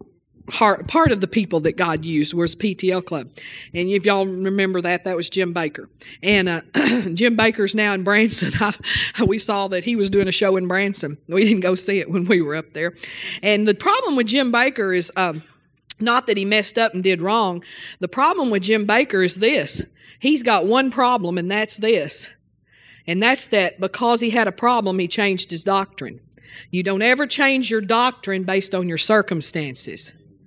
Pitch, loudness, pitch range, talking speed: 195 Hz, -19 LUFS, 180-225 Hz, 195 wpm